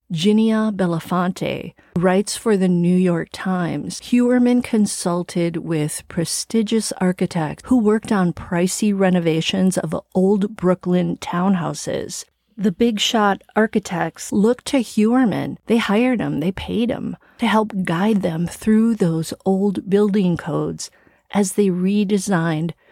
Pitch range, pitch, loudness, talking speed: 175-220 Hz, 195 Hz, -19 LUFS, 125 wpm